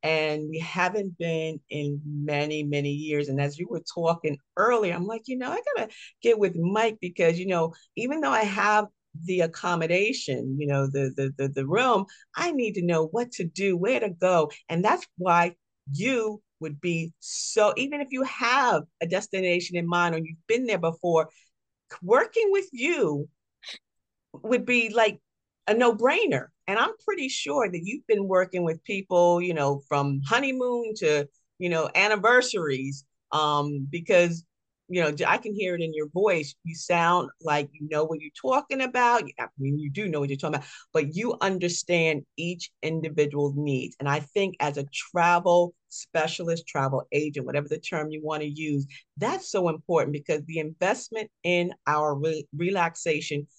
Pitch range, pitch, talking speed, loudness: 150-205 Hz, 170 Hz, 175 wpm, -26 LUFS